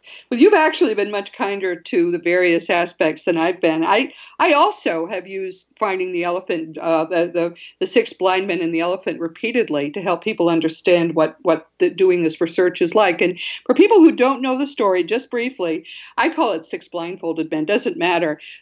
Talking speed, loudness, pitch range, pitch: 200 wpm, -18 LUFS, 170-240 Hz, 180 Hz